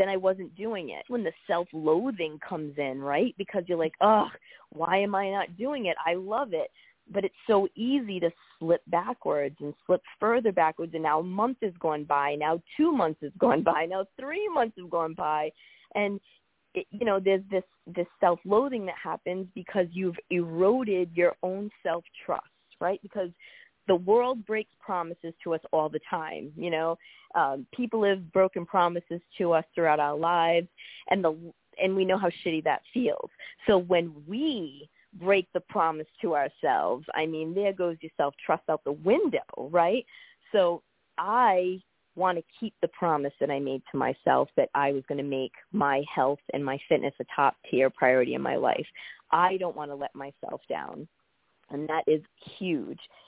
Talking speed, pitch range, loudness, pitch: 180 wpm, 155-200 Hz, -28 LUFS, 175 Hz